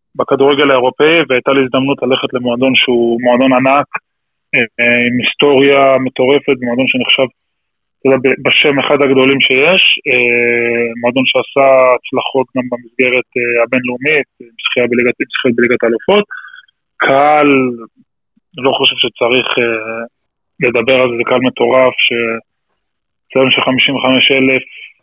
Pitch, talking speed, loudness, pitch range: 130 Hz, 105 wpm, -11 LUFS, 120-135 Hz